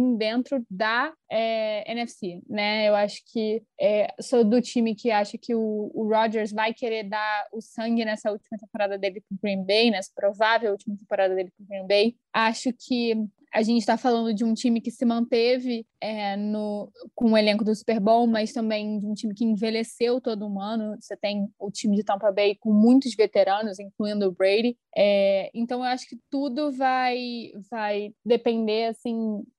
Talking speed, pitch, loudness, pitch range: 190 wpm, 220 Hz, -25 LUFS, 210-235 Hz